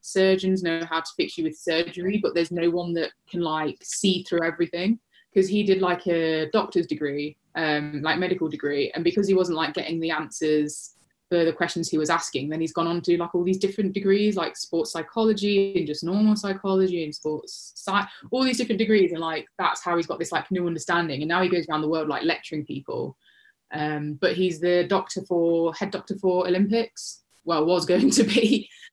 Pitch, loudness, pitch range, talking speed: 175 Hz, -24 LUFS, 165-195 Hz, 210 wpm